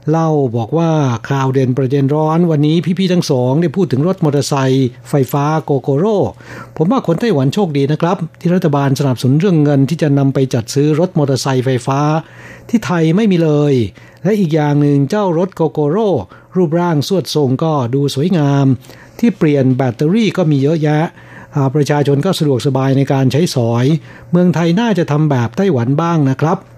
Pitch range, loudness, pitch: 135-170 Hz, -14 LUFS, 150 Hz